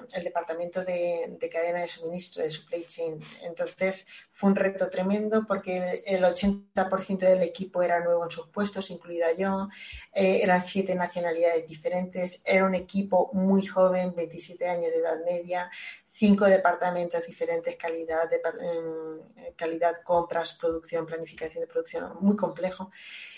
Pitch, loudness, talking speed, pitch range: 180 Hz, -28 LUFS, 145 wpm, 170-190 Hz